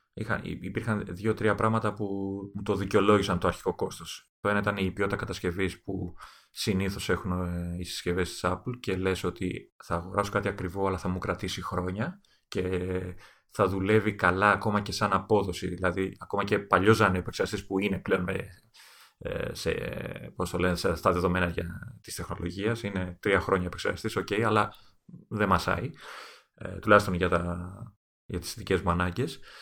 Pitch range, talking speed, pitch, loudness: 90-105 Hz, 150 wpm, 95 Hz, -29 LUFS